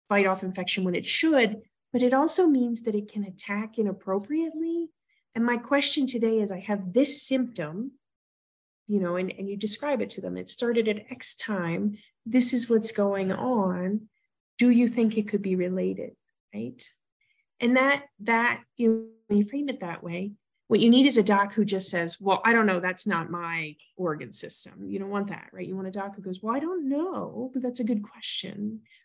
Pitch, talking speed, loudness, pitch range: 215 Hz, 205 wpm, -26 LUFS, 190-250 Hz